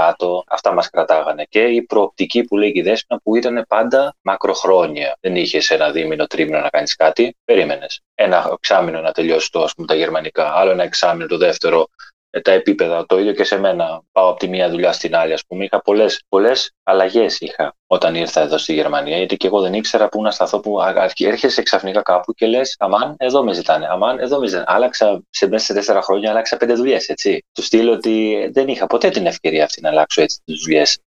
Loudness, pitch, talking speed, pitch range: -16 LUFS, 110 Hz, 205 wpm, 95-135 Hz